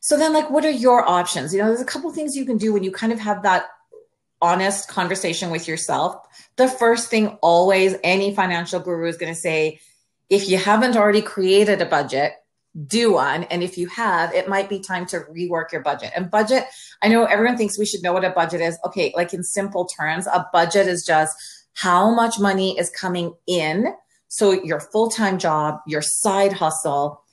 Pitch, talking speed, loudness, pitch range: 190 Hz, 205 wpm, -20 LUFS, 170-215 Hz